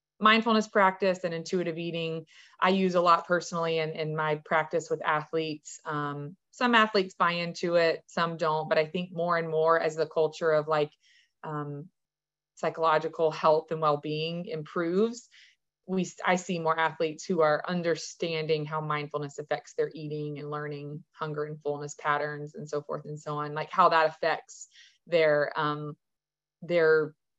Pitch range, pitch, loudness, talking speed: 150-170 Hz, 160 Hz, -28 LUFS, 160 wpm